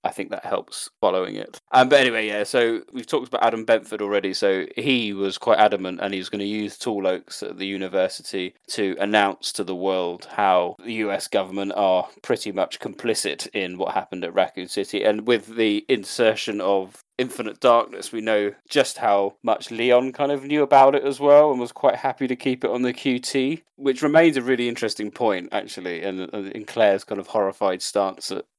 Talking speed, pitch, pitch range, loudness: 205 wpm, 110 Hz, 100-130 Hz, -22 LUFS